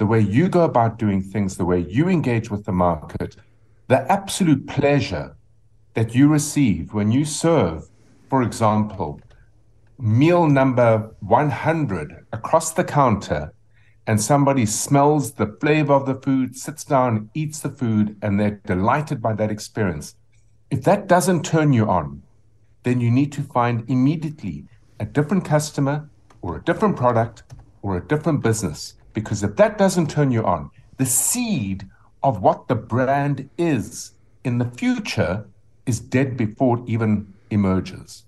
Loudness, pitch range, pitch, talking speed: -20 LUFS, 105-145 Hz, 115 Hz, 150 wpm